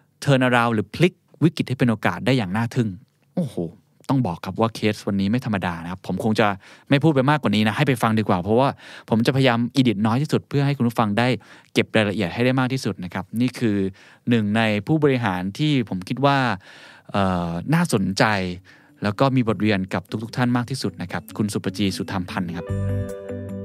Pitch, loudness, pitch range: 110 Hz, -22 LUFS, 100-130 Hz